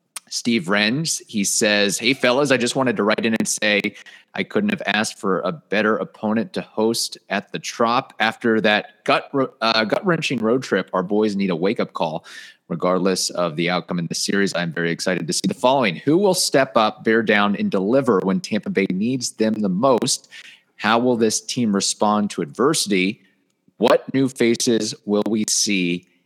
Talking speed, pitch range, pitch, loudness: 190 wpm, 100-115 Hz, 105 Hz, -20 LUFS